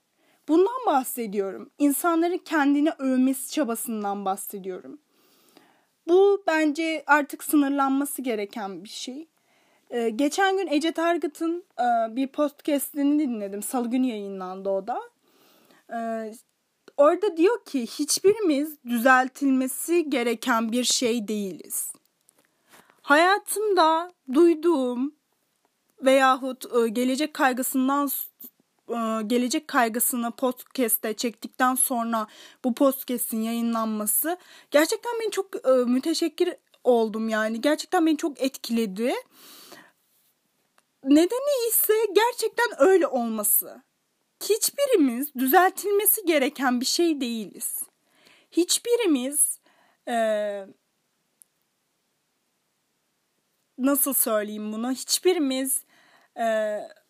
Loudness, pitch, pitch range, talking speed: -24 LUFS, 275 Hz, 240-335 Hz, 80 wpm